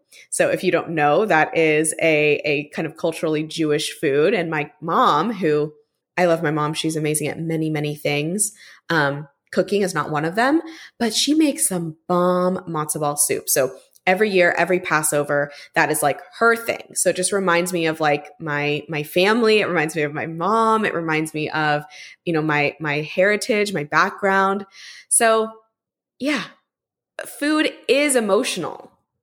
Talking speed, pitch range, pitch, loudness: 175 wpm, 150-205 Hz, 165 Hz, -20 LUFS